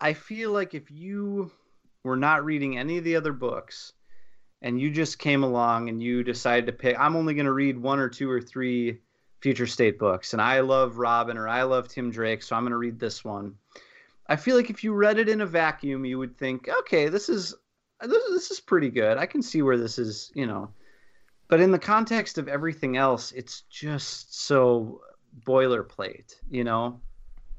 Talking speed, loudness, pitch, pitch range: 200 wpm, -26 LUFS, 130 Hz, 120-160 Hz